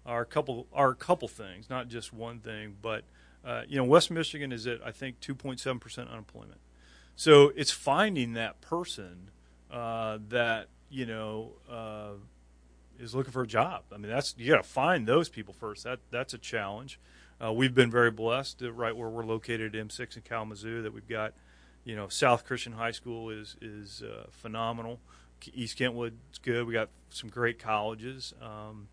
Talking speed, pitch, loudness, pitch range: 185 wpm, 115 Hz, -30 LUFS, 105-125 Hz